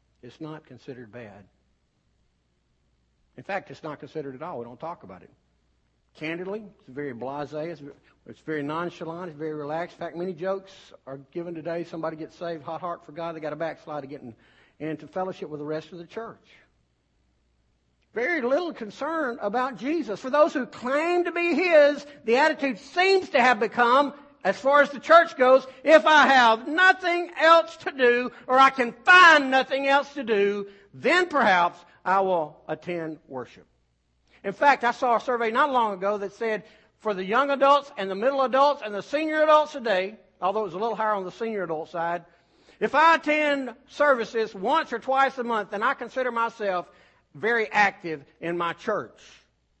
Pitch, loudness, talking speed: 200 Hz, -23 LUFS, 185 wpm